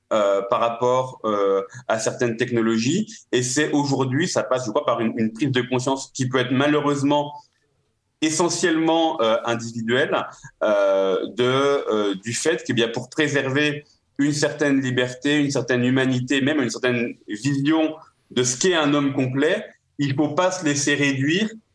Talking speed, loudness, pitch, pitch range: 160 wpm, -21 LUFS, 135 Hz, 120-145 Hz